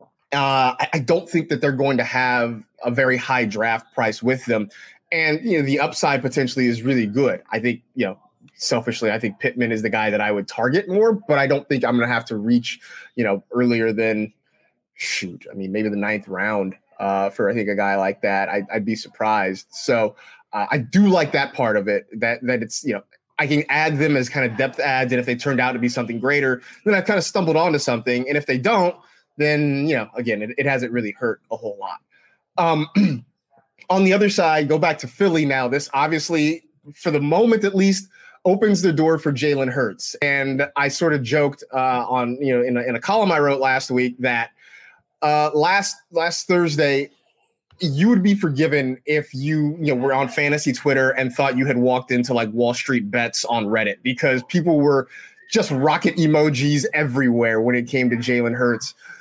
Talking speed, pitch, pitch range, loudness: 215 wpm, 135 Hz, 120-155 Hz, -20 LUFS